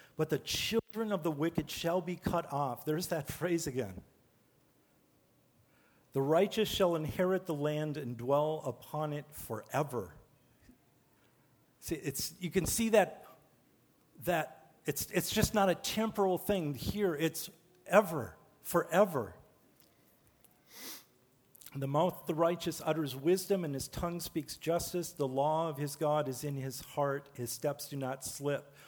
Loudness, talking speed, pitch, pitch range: -34 LUFS, 145 wpm, 155 Hz, 140-175 Hz